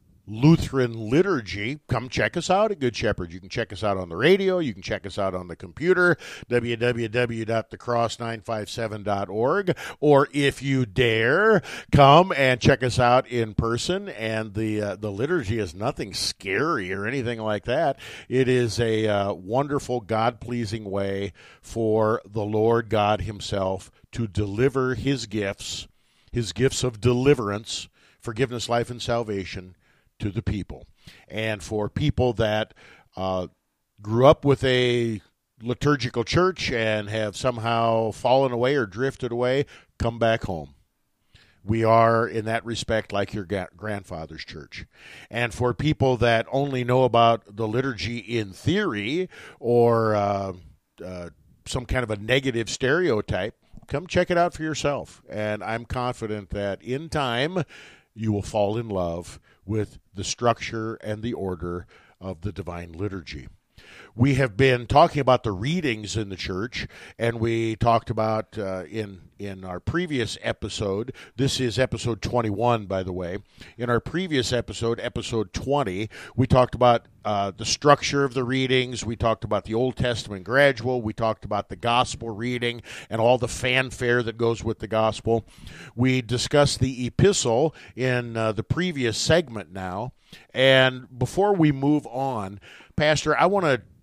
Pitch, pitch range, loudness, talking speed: 115 Hz, 105-130 Hz, -24 LUFS, 155 wpm